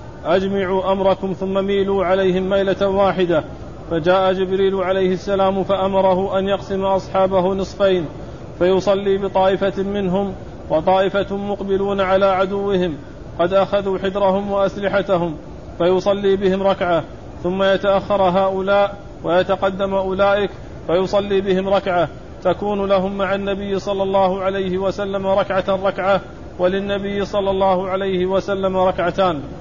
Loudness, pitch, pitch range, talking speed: -18 LUFS, 195 Hz, 185-195 Hz, 110 wpm